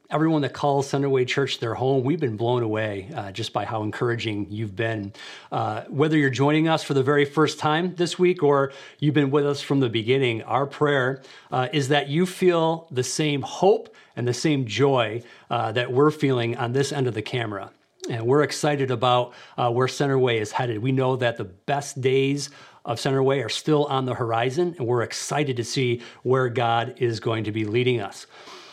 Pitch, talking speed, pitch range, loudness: 130 Hz, 205 wpm, 120-145 Hz, -23 LUFS